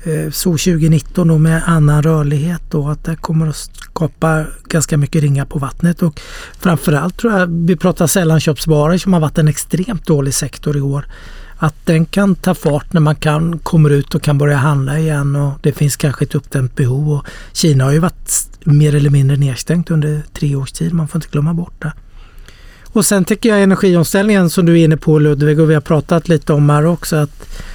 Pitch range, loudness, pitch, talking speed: 145-170 Hz, -14 LUFS, 155 Hz, 205 wpm